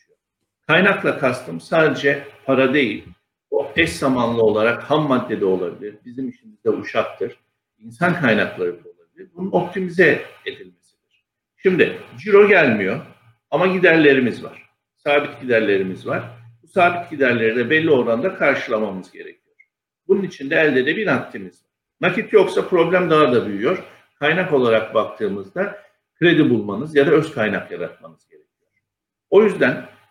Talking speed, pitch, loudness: 130 wpm, 155 Hz, -18 LUFS